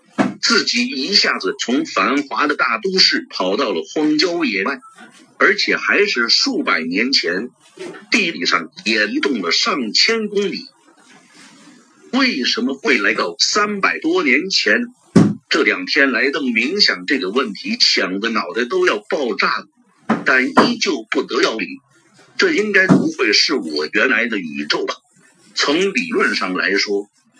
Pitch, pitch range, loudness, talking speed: 265 Hz, 235-330 Hz, -16 LUFS, 210 characters per minute